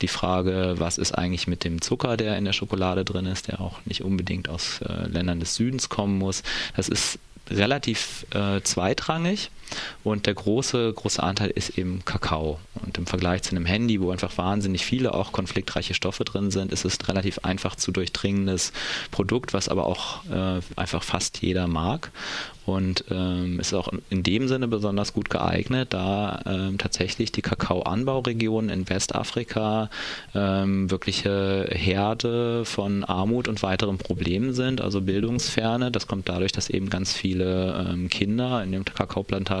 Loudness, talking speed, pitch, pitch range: -26 LUFS, 165 wpm, 95 Hz, 90-110 Hz